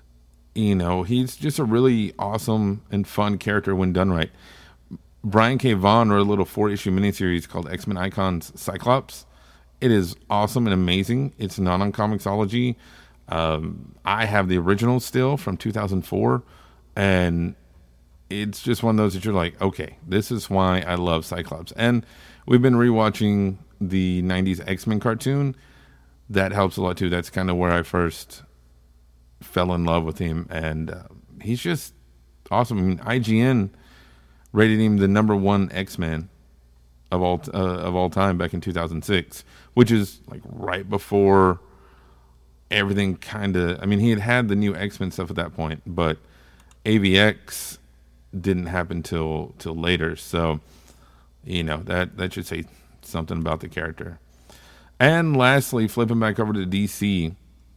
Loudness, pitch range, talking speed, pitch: -22 LUFS, 80-105 Hz, 160 wpm, 95 Hz